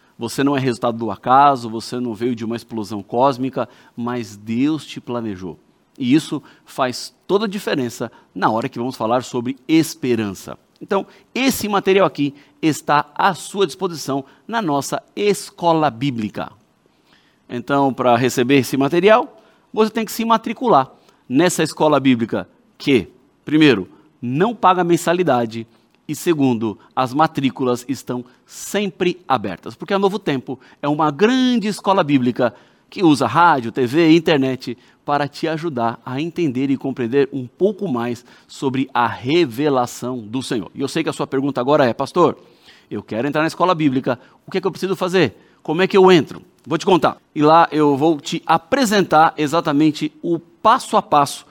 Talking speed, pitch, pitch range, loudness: 160 wpm, 140 Hz, 125-170 Hz, -18 LUFS